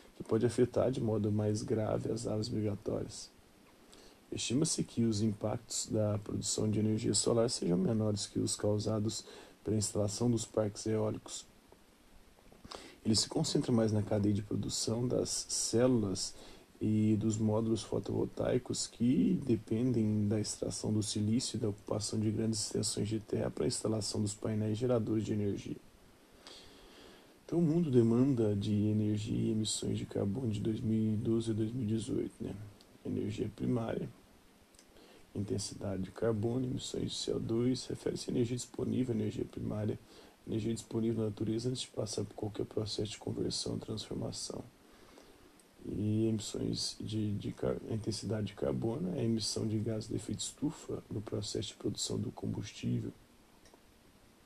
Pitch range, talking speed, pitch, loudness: 105-115 Hz, 140 wpm, 110 Hz, -35 LUFS